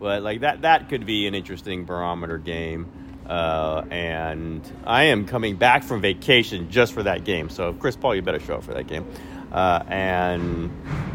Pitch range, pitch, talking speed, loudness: 85-115 Hz, 90 Hz, 185 wpm, -23 LUFS